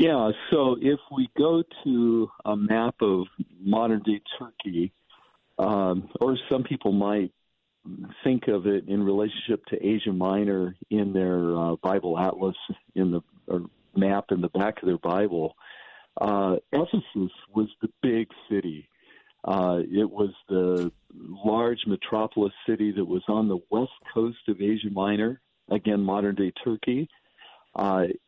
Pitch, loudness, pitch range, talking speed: 100 Hz, -26 LUFS, 95-110 Hz, 140 wpm